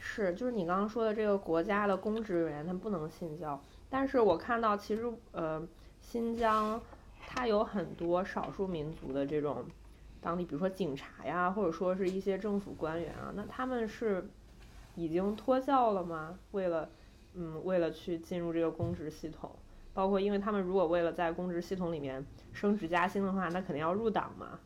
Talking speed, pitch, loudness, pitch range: 280 characters per minute, 185 Hz, -34 LUFS, 165-210 Hz